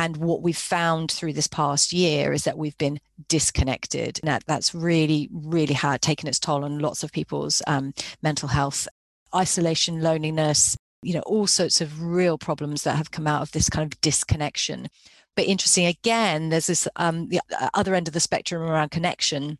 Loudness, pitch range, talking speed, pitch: -23 LUFS, 150-170 Hz, 185 wpm, 155 Hz